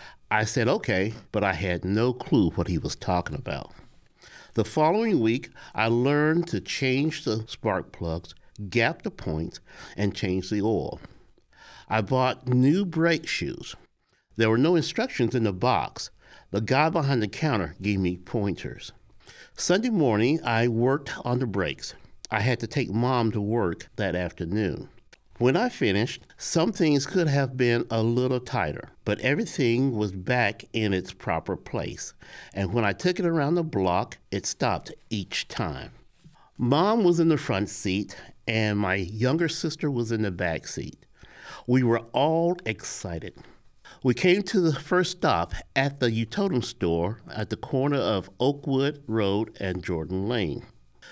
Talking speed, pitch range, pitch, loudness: 160 wpm, 105-145 Hz, 120 Hz, -26 LUFS